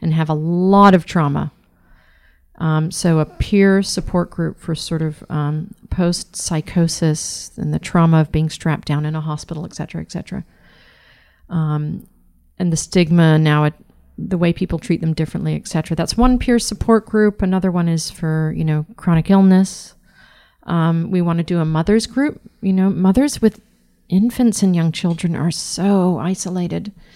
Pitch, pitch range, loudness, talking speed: 170 Hz, 160-190 Hz, -17 LUFS, 170 wpm